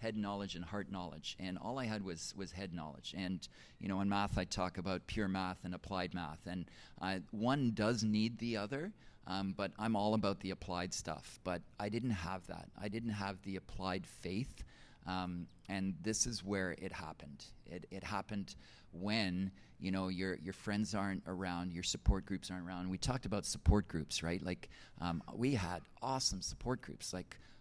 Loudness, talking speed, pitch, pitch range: -40 LUFS, 195 wpm, 95 Hz, 90-105 Hz